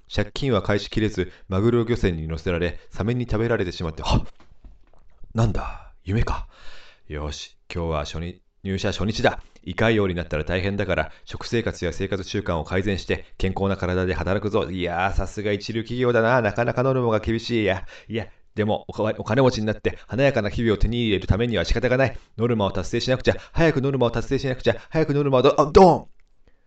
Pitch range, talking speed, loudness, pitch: 90-115 Hz, 395 characters per minute, -23 LUFS, 105 Hz